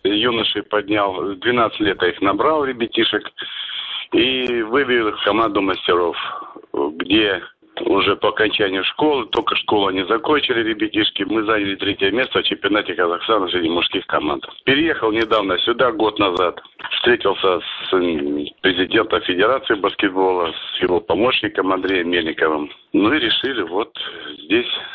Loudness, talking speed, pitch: -18 LUFS, 125 wpm, 120 Hz